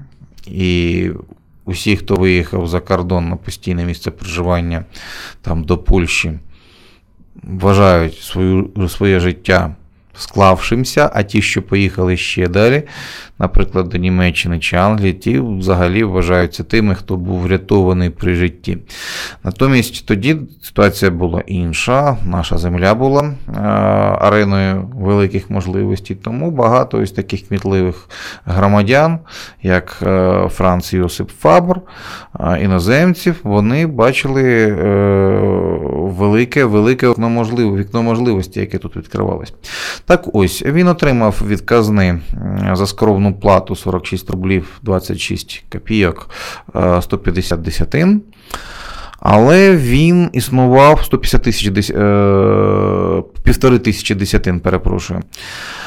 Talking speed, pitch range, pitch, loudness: 100 wpm, 90-115 Hz, 100 Hz, -14 LUFS